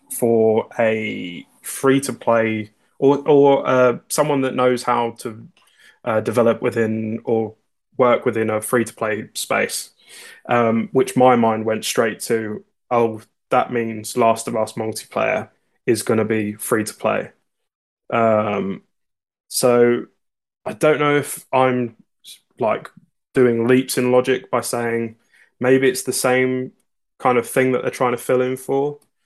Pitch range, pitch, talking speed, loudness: 110-130 Hz, 120 Hz, 150 wpm, -19 LUFS